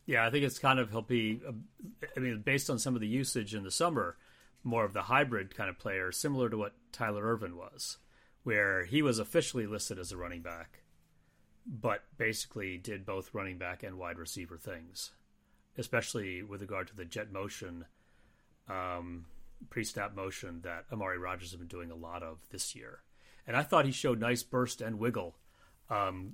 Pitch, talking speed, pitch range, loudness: 105 Hz, 190 wpm, 90-120 Hz, -35 LUFS